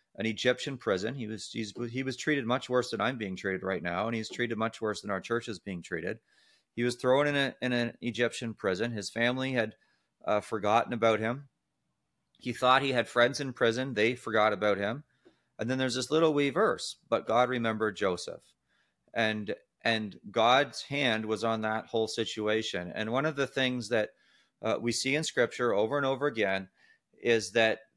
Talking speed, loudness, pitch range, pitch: 195 wpm, -30 LUFS, 110-130 Hz, 115 Hz